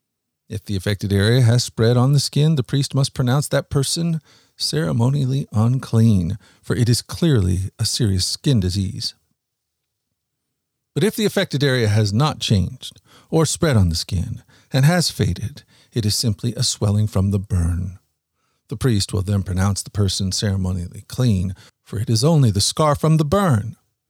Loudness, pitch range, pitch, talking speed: -19 LUFS, 100-135 Hz, 115 Hz, 165 wpm